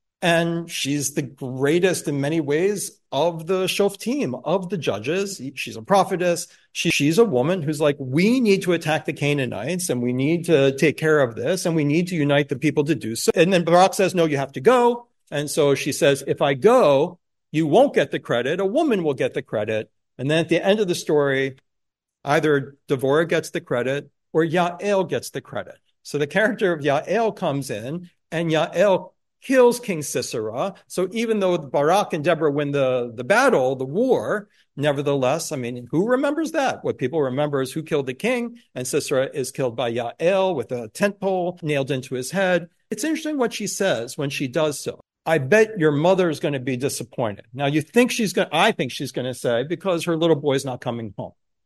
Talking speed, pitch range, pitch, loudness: 210 wpm, 140-185 Hz, 160 Hz, -21 LUFS